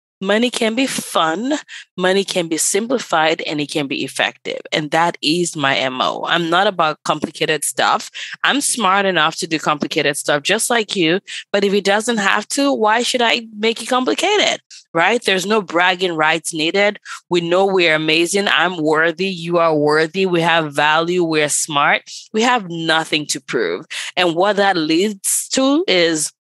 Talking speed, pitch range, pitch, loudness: 170 wpm, 160-215 Hz, 185 Hz, -16 LUFS